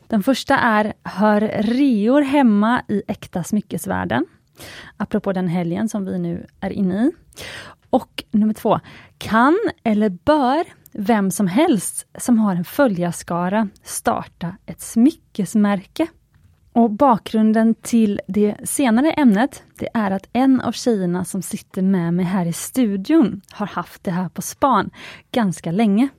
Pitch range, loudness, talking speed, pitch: 195-245 Hz, -19 LUFS, 140 wpm, 215 Hz